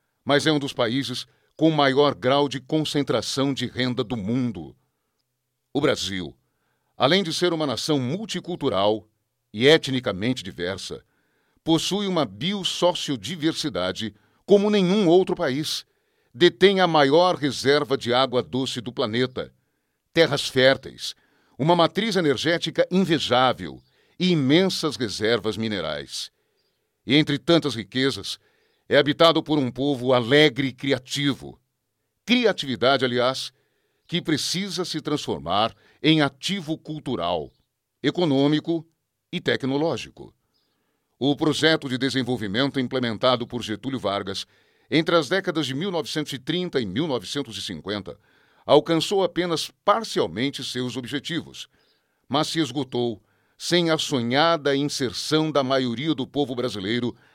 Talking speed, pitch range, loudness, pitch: 110 wpm, 125-160 Hz, -23 LUFS, 140 Hz